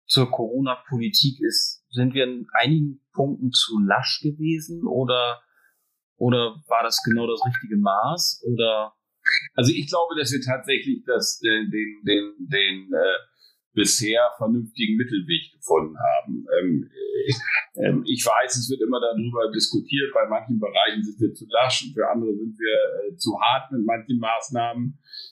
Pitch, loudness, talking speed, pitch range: 130 Hz, -23 LUFS, 155 wpm, 115-165 Hz